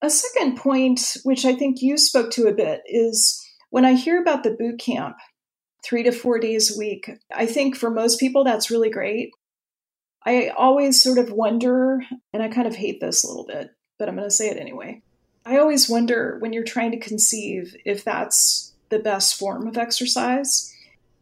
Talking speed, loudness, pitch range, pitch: 195 wpm, -20 LUFS, 225-260 Hz, 240 Hz